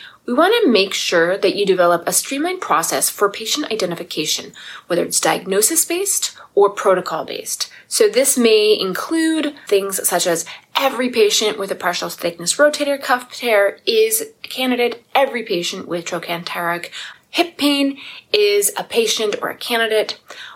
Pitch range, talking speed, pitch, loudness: 190-300 Hz, 150 wpm, 230 Hz, -17 LUFS